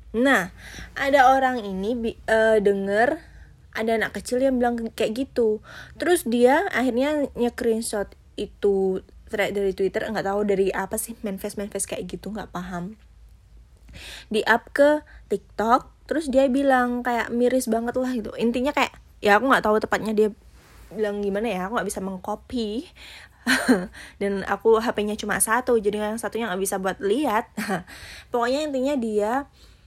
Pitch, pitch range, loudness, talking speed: 220 Hz, 205-250 Hz, -23 LUFS, 150 wpm